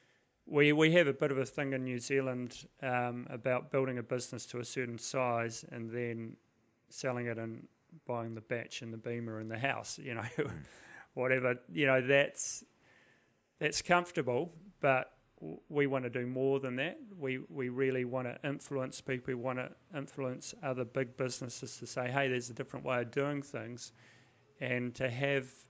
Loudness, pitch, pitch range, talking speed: -35 LUFS, 130 Hz, 120-140 Hz, 180 wpm